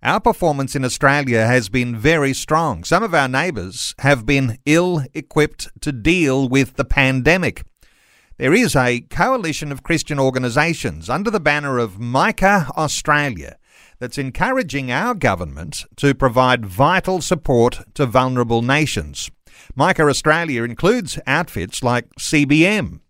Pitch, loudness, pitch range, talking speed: 140 Hz, -17 LUFS, 125-155 Hz, 130 wpm